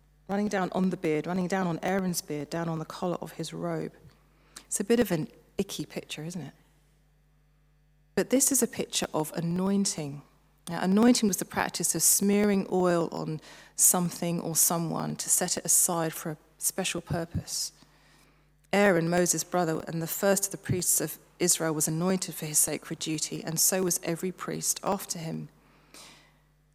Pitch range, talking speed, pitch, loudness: 155-185 Hz, 175 wpm, 170 Hz, -27 LUFS